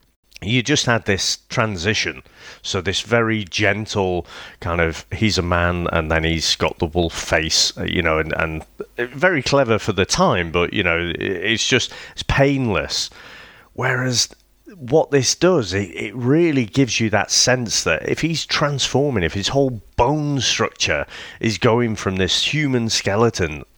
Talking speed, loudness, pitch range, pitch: 160 wpm, -19 LUFS, 90-130 Hz, 110 Hz